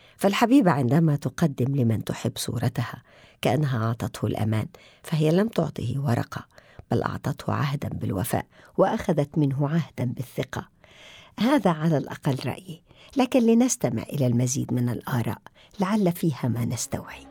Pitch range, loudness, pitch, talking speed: 120-170 Hz, -25 LUFS, 140 Hz, 120 wpm